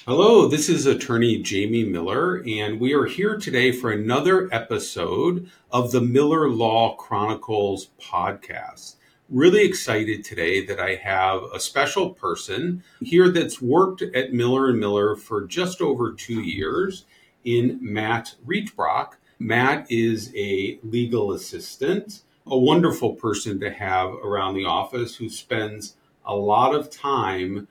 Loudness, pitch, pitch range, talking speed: -22 LUFS, 115 Hz, 105-150 Hz, 135 wpm